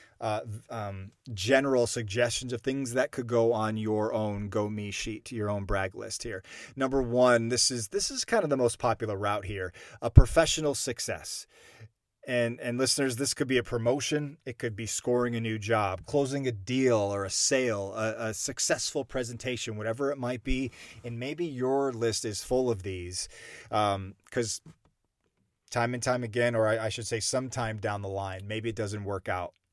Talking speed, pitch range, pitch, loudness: 190 wpm, 105-130 Hz, 120 Hz, -29 LUFS